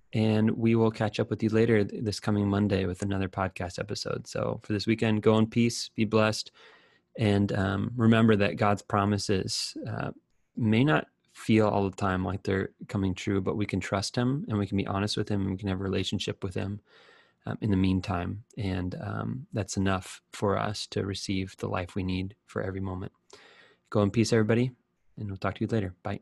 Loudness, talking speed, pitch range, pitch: -28 LUFS, 210 wpm, 95-110 Hz, 105 Hz